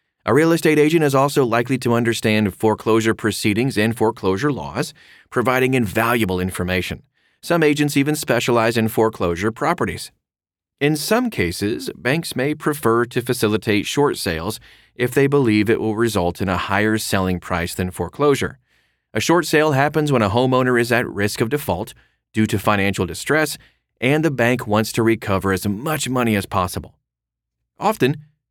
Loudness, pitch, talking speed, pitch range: -19 LUFS, 115 Hz, 160 wpm, 100-140 Hz